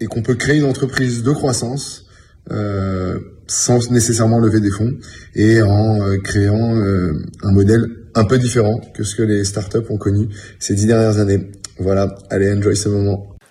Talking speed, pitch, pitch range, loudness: 180 wpm, 105 Hz, 100-115 Hz, -16 LUFS